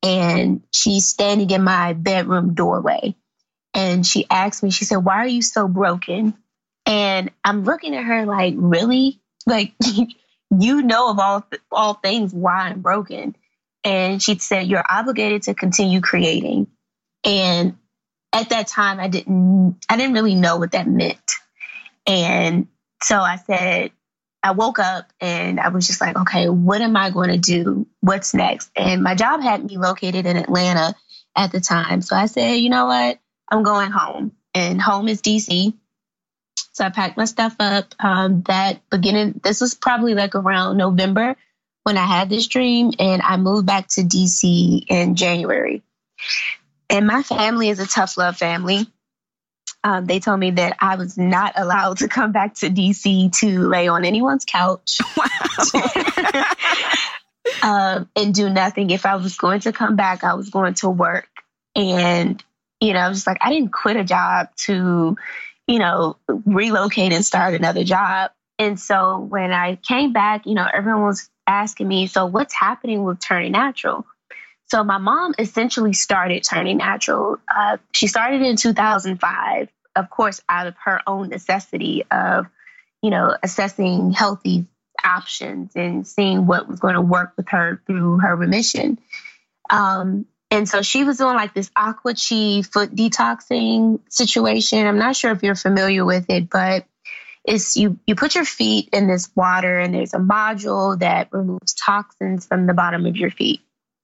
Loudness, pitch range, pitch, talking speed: -18 LUFS, 185-215 Hz, 195 Hz, 170 wpm